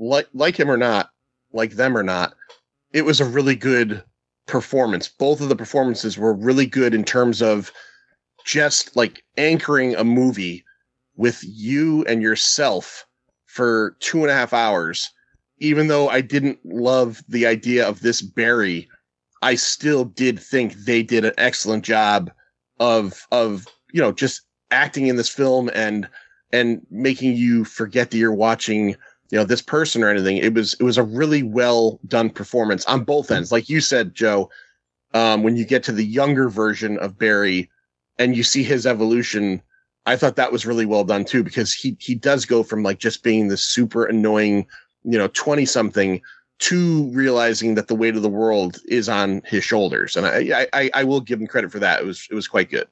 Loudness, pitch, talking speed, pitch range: -19 LUFS, 115 Hz, 185 wpm, 110-130 Hz